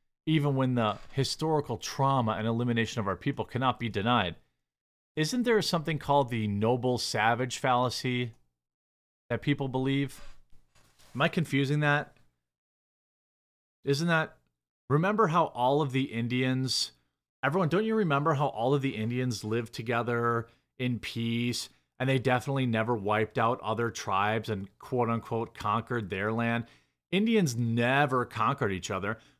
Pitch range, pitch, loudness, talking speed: 110-140 Hz, 120 Hz, -29 LUFS, 140 wpm